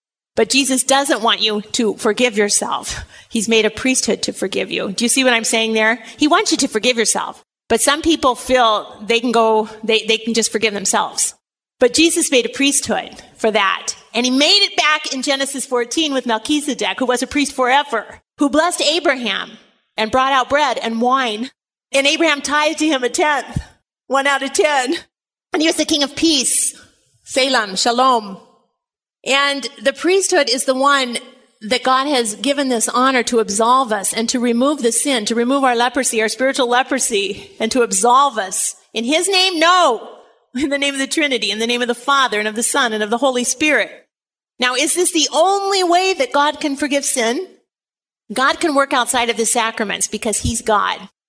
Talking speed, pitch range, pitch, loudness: 200 wpm, 230-285 Hz, 255 Hz, -16 LUFS